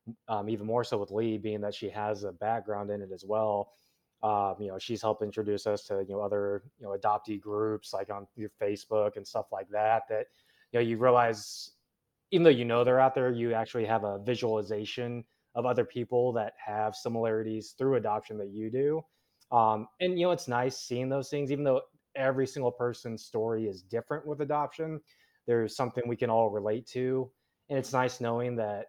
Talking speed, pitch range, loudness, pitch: 205 wpm, 105-125 Hz, -31 LUFS, 115 Hz